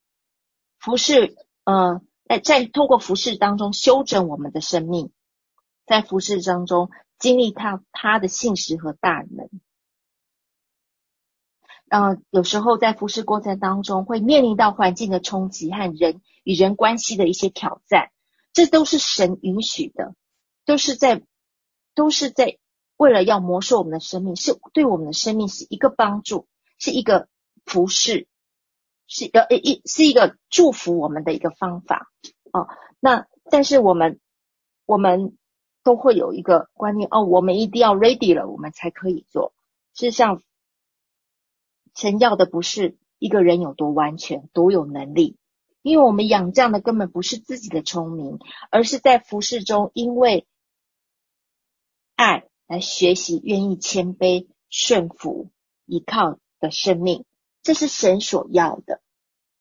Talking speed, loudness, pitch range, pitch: 220 characters per minute, -19 LUFS, 180-245 Hz, 205 Hz